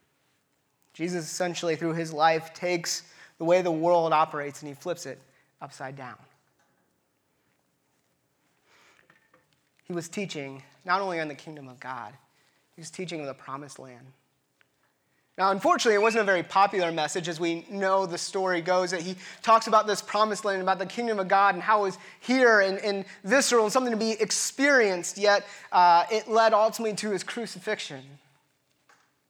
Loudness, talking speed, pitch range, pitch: -25 LUFS, 165 wpm, 150-205 Hz, 180 Hz